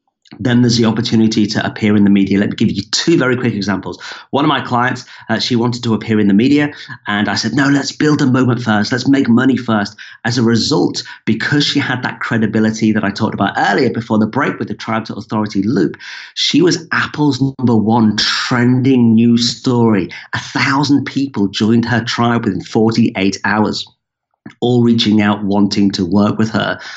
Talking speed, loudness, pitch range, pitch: 200 wpm, -14 LUFS, 105-125 Hz, 115 Hz